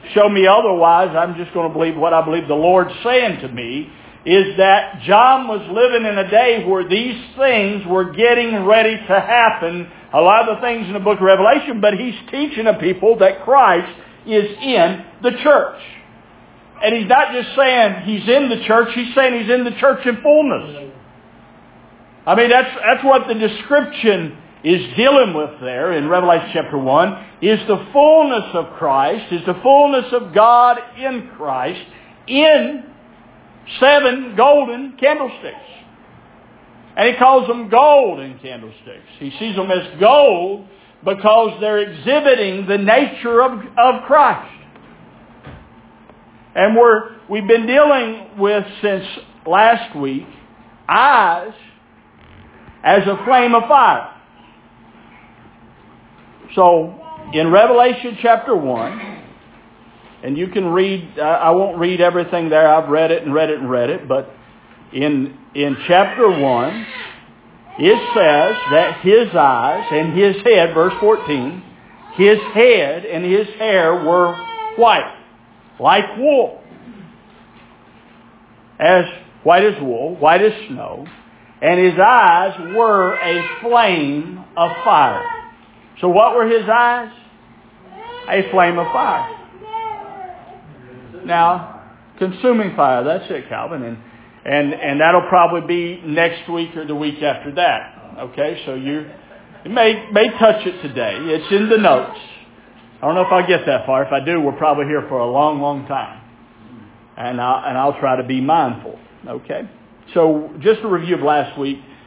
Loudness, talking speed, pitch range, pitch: -14 LUFS, 145 wpm, 165-240 Hz, 200 Hz